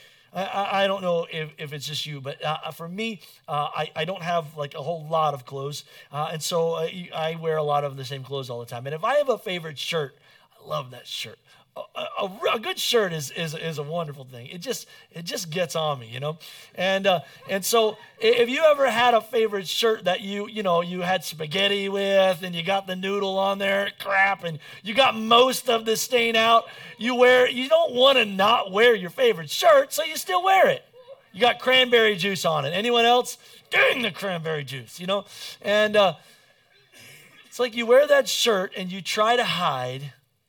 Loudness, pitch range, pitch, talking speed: -23 LUFS, 160-230 Hz, 195 Hz, 220 wpm